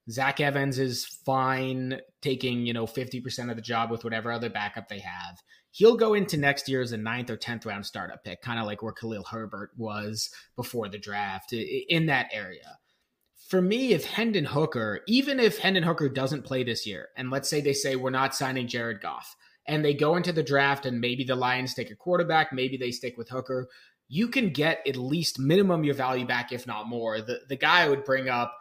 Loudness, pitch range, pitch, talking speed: -27 LUFS, 120-150 Hz, 130 Hz, 220 wpm